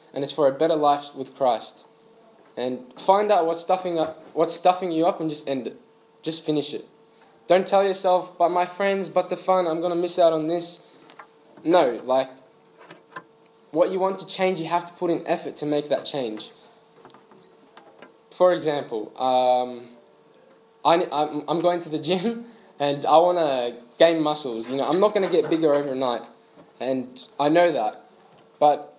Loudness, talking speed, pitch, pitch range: -23 LUFS, 180 wpm, 165 Hz, 140-180 Hz